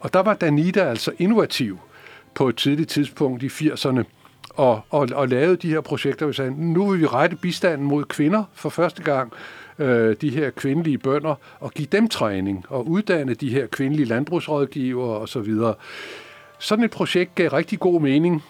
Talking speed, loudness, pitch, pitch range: 180 wpm, -21 LUFS, 150 Hz, 135-175 Hz